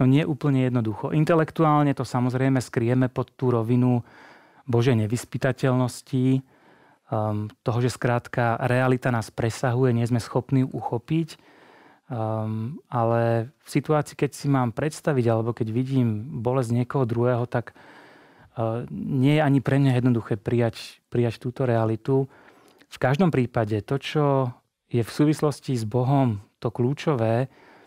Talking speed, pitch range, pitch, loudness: 140 wpm, 120-135 Hz, 125 Hz, -24 LUFS